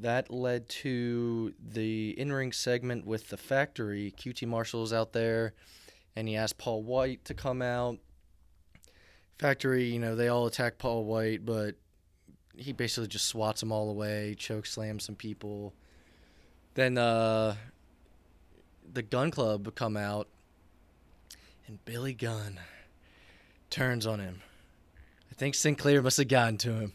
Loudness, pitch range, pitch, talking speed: -32 LUFS, 95-120 Hz, 110 Hz, 140 wpm